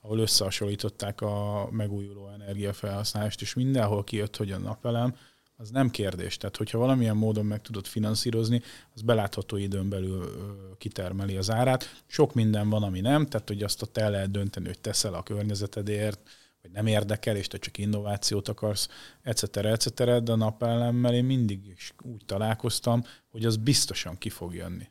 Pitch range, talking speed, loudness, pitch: 100-115 Hz, 165 wpm, -28 LUFS, 105 Hz